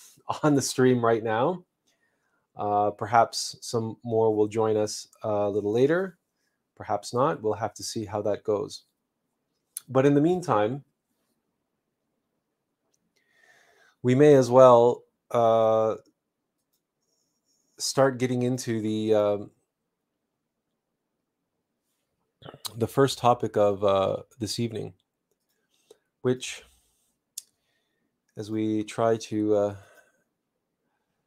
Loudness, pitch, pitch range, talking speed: -24 LUFS, 115 Hz, 105-130 Hz, 100 wpm